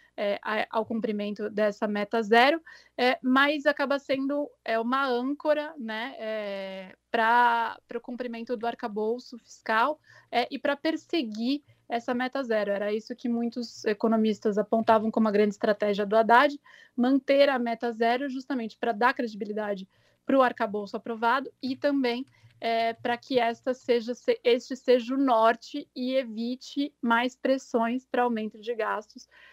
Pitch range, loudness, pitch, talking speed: 225-265 Hz, -27 LUFS, 240 Hz, 145 wpm